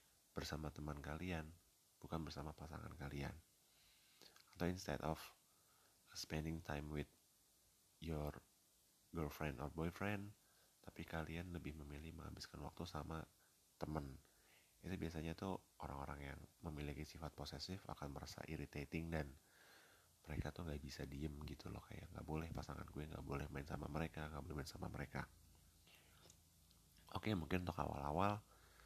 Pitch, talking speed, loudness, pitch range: 80 Hz, 135 wpm, -49 LUFS, 75-85 Hz